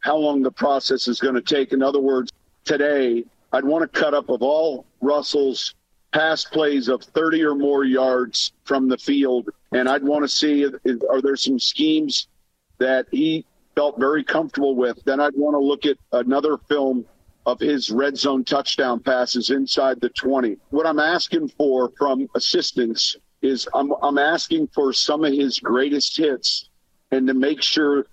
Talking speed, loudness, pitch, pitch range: 180 wpm, -20 LUFS, 140 Hz, 130-150 Hz